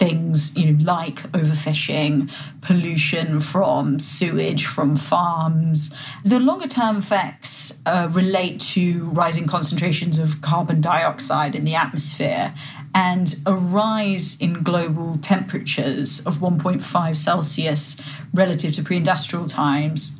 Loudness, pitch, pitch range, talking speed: -20 LUFS, 160 Hz, 150-180 Hz, 115 wpm